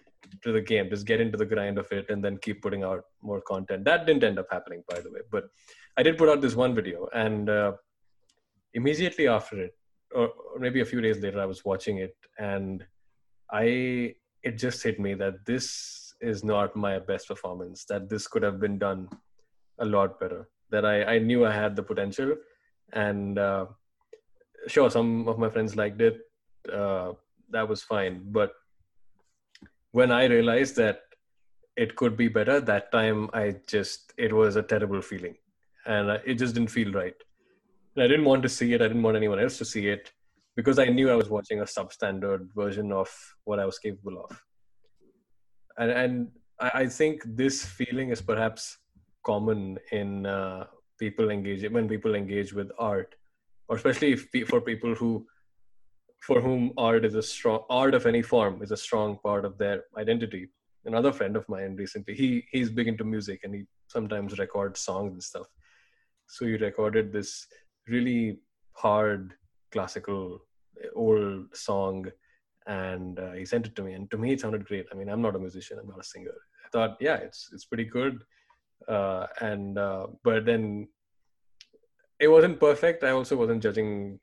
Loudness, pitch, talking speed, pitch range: -27 LUFS, 110 Hz, 180 wpm, 100-125 Hz